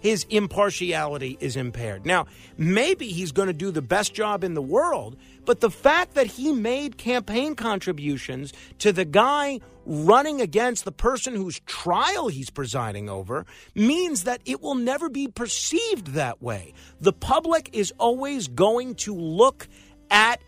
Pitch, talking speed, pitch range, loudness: 210 Hz, 155 wpm, 155-250 Hz, -24 LUFS